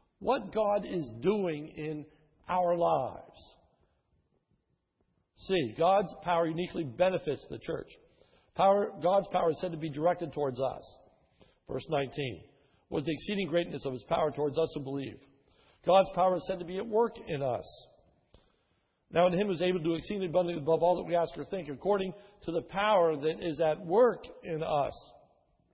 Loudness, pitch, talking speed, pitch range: -31 LUFS, 170 Hz, 170 wpm, 155-190 Hz